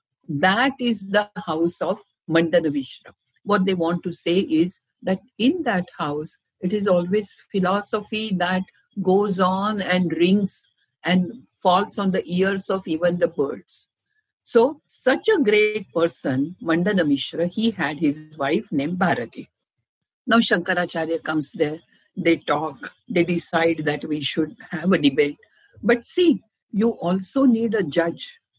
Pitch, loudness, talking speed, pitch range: 185 Hz, -22 LUFS, 145 wpm, 165-210 Hz